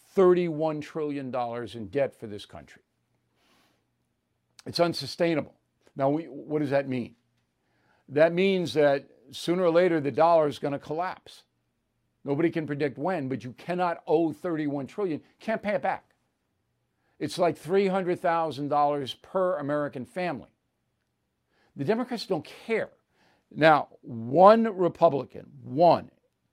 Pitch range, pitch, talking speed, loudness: 135-175 Hz, 150 Hz, 125 wpm, -26 LUFS